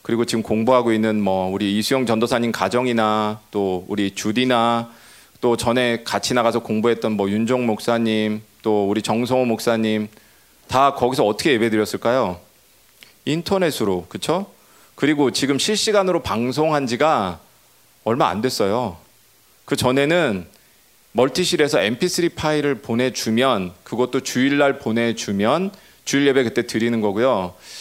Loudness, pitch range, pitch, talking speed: -20 LUFS, 110-135 Hz, 120 Hz, 300 characters per minute